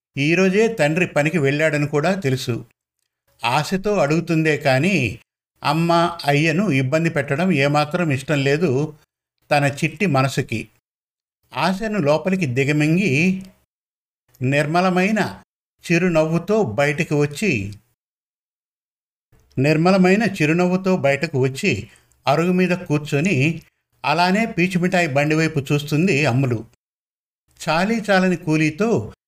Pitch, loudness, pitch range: 155 Hz, -19 LUFS, 140-180 Hz